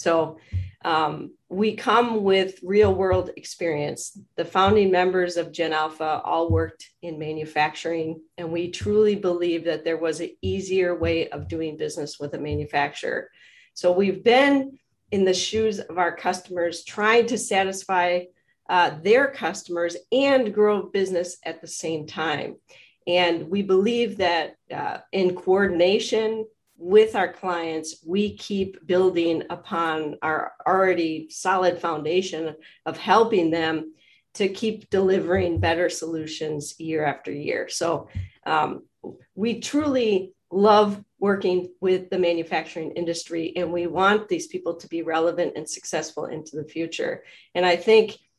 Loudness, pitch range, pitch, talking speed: -23 LUFS, 165-195 Hz, 180 Hz, 140 wpm